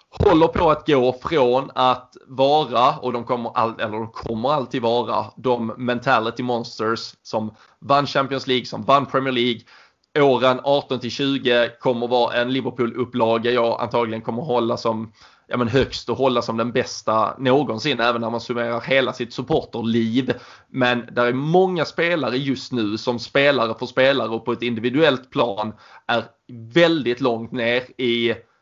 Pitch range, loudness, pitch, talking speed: 115-130 Hz, -21 LUFS, 125 Hz, 155 wpm